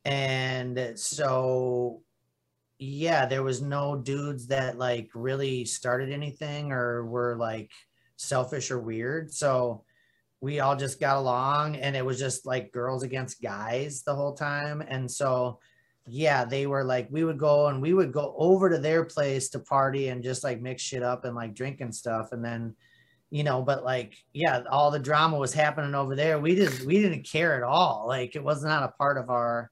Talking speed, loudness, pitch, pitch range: 190 wpm, -28 LUFS, 135 Hz, 125-145 Hz